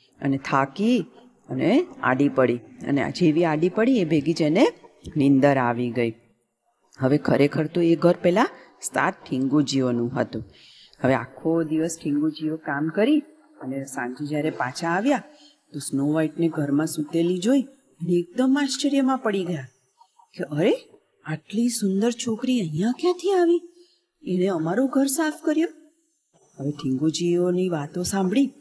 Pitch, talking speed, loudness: 175 Hz, 120 wpm, -23 LUFS